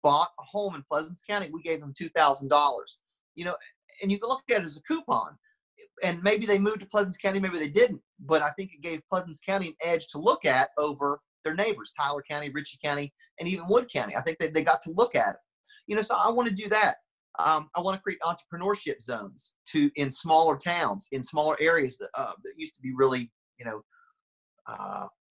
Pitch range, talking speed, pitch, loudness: 150-210 Hz, 230 wpm, 170 Hz, -28 LUFS